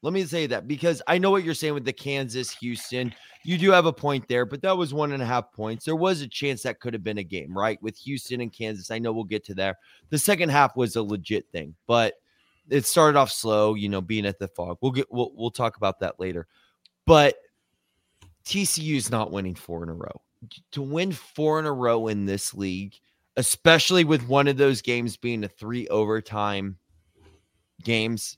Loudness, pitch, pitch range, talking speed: -24 LUFS, 120 Hz, 105-145 Hz, 220 wpm